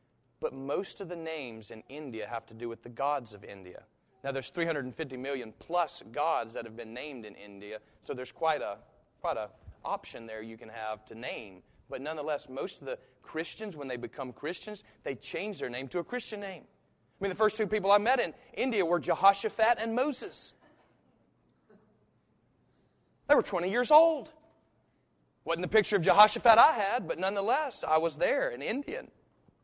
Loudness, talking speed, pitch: -31 LUFS, 185 wpm, 160 Hz